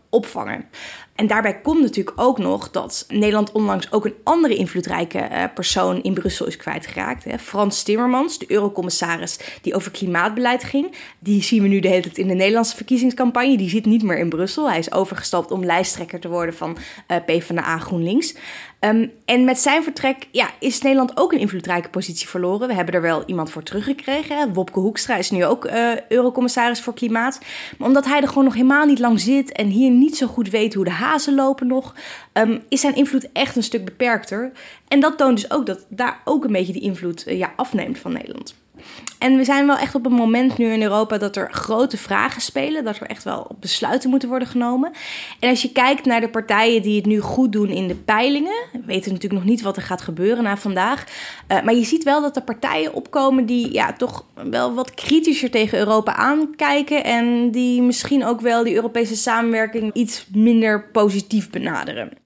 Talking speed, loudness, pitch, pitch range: 200 wpm, -19 LUFS, 235 Hz, 205-265 Hz